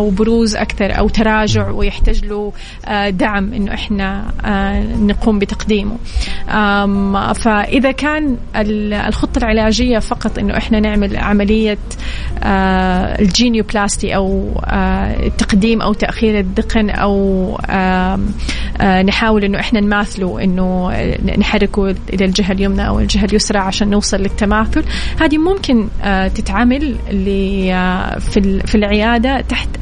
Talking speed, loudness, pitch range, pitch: 105 wpm, -15 LUFS, 195-220 Hz, 205 Hz